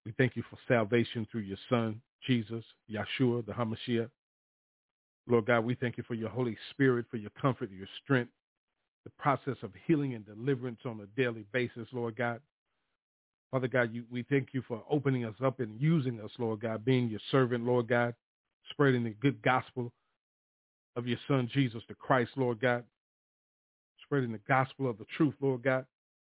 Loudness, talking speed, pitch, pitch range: -32 LUFS, 175 wpm, 120 Hz, 115-130 Hz